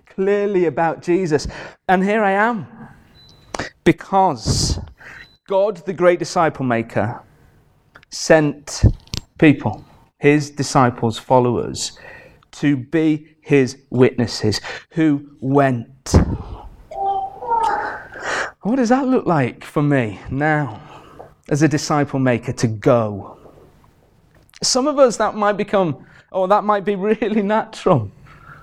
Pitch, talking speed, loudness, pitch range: 155 Hz, 105 wpm, -18 LUFS, 135-200 Hz